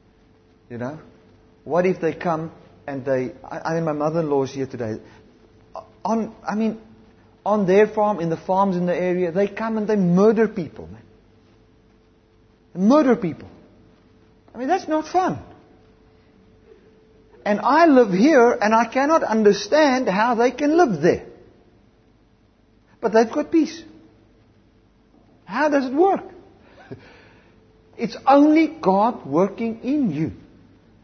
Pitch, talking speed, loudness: 185 Hz, 130 wpm, -20 LUFS